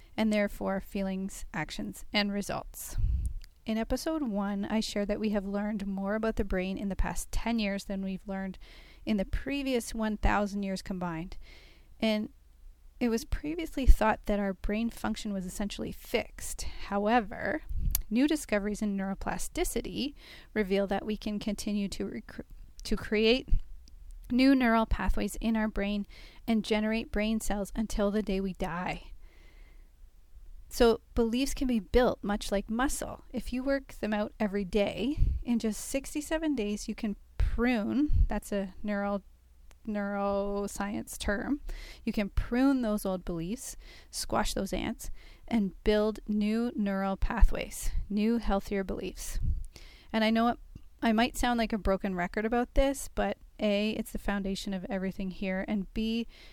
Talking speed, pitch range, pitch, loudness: 150 wpm, 195-230 Hz, 210 Hz, -32 LUFS